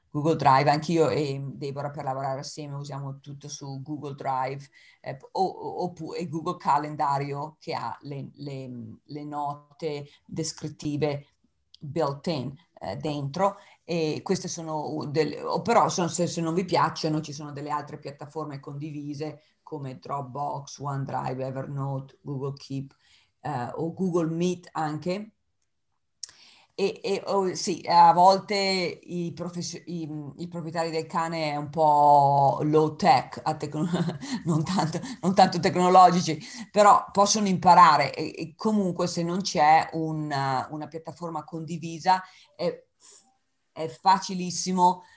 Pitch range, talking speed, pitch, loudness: 145-175 Hz, 130 wpm, 155 Hz, -25 LUFS